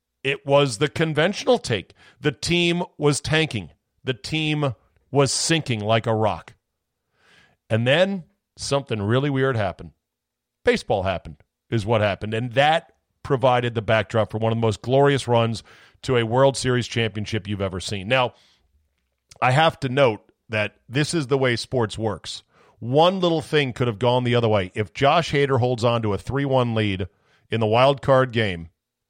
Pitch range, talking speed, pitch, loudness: 110-140 Hz, 170 wpm, 120 Hz, -22 LUFS